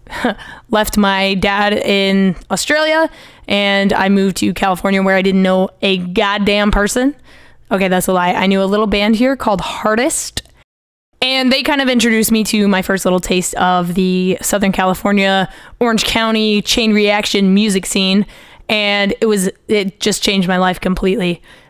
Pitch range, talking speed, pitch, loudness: 190-215 Hz, 165 wpm, 200 Hz, -14 LUFS